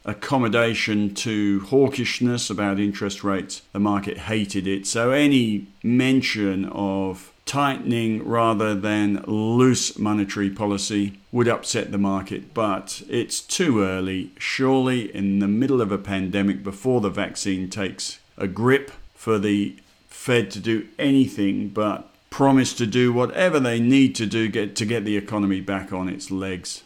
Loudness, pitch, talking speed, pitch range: -22 LUFS, 105 Hz, 145 wpm, 100-120 Hz